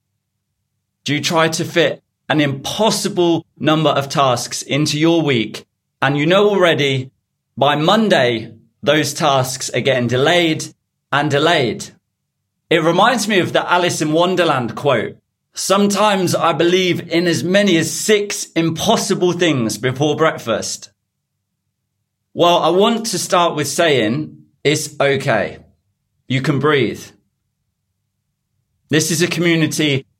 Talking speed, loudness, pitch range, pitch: 125 wpm, -16 LUFS, 125-170 Hz, 150 Hz